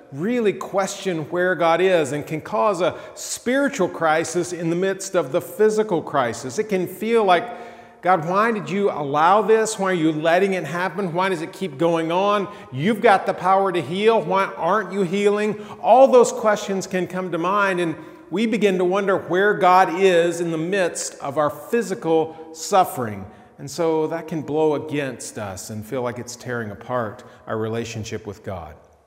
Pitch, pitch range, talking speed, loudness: 180 Hz, 155-200 Hz, 185 wpm, -20 LUFS